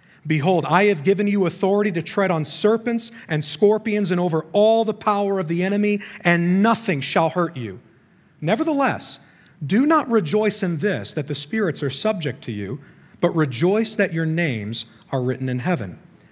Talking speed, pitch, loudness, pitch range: 175 wpm, 180 Hz, -21 LUFS, 155-210 Hz